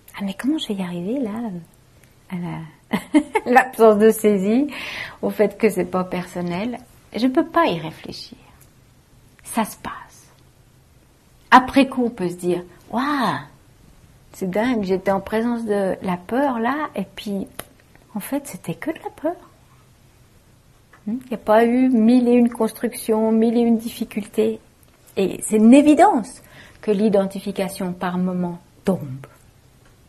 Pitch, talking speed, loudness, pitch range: 210 Hz, 150 wpm, -20 LUFS, 180-235 Hz